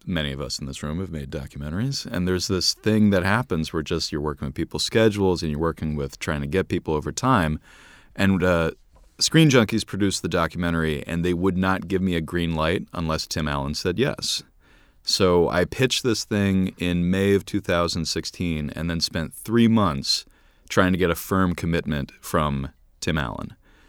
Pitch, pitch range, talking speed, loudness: 85 Hz, 75-95 Hz, 190 wpm, -23 LUFS